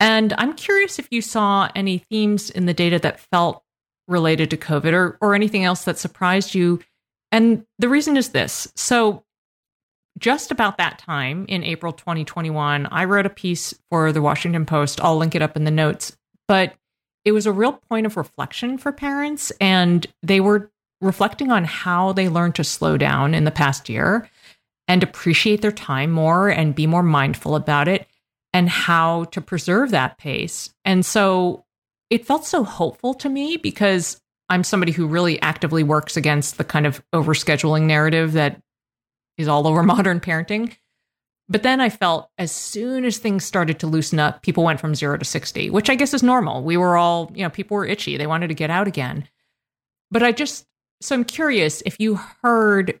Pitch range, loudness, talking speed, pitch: 155-210 Hz, -19 LUFS, 190 wpm, 180 Hz